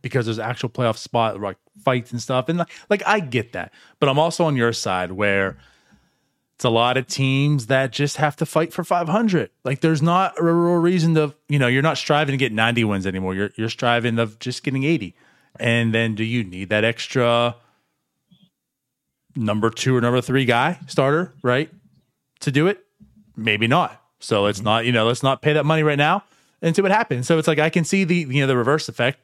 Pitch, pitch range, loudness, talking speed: 135 Hz, 115-160 Hz, -20 LUFS, 220 wpm